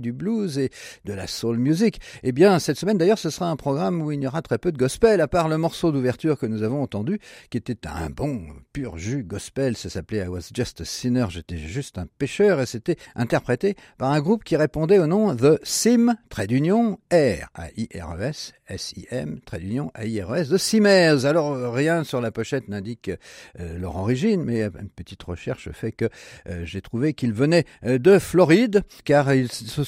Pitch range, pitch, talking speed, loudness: 110-170 Hz, 135 Hz, 210 wpm, -22 LUFS